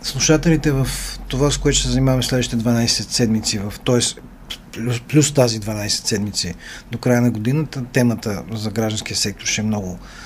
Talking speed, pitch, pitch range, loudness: 170 wpm, 120 Hz, 110-130 Hz, -19 LUFS